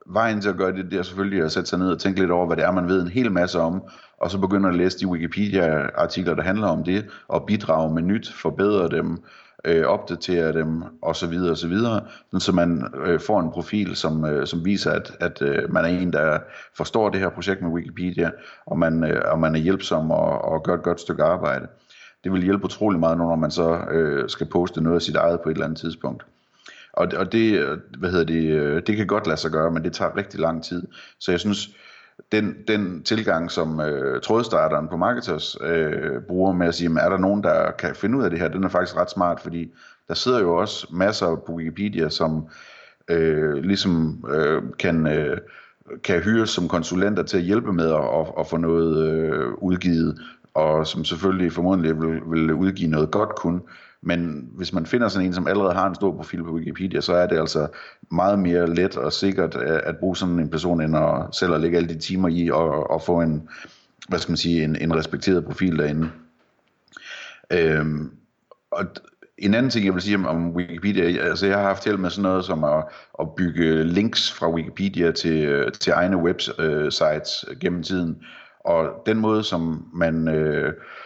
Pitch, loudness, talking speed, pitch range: 85 Hz, -22 LUFS, 210 wpm, 80-95 Hz